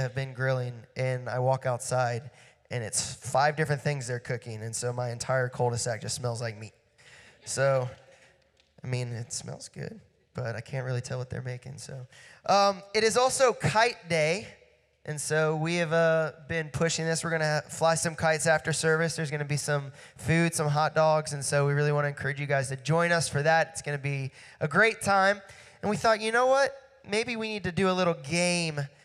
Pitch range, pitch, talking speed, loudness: 130-165 Hz, 150 Hz, 210 wpm, -28 LUFS